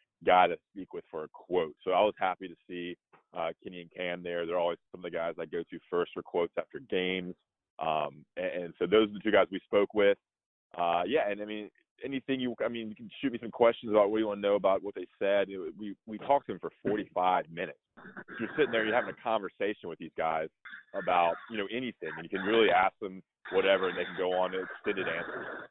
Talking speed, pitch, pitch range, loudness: 250 wpm, 100 Hz, 90-110 Hz, -31 LUFS